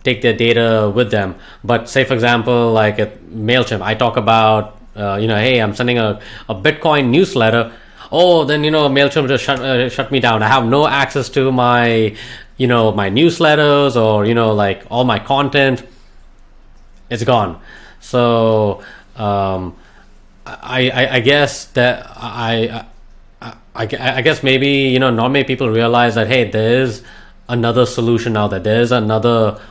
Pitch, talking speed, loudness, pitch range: 120 Hz, 170 wpm, -14 LUFS, 110-130 Hz